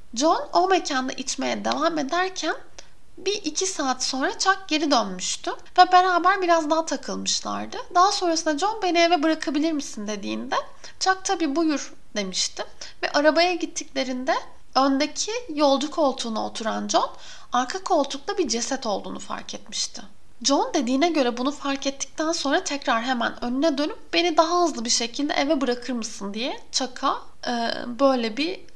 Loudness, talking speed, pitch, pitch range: -23 LUFS, 145 wpm, 300 Hz, 260-345 Hz